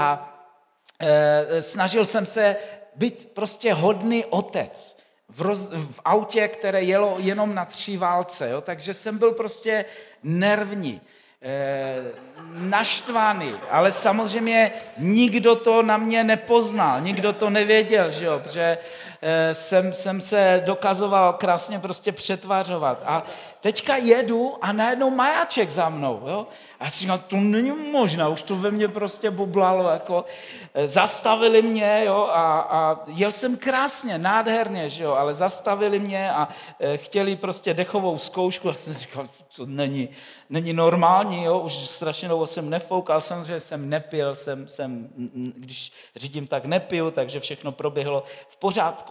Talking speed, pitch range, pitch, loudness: 145 wpm, 160-210 Hz, 185 Hz, -22 LUFS